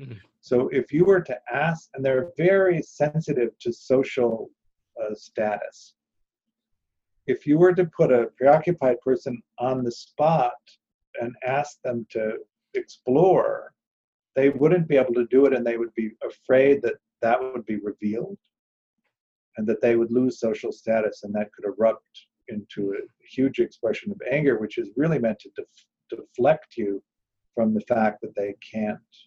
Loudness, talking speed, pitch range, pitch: -24 LUFS, 160 wpm, 115-155 Hz, 130 Hz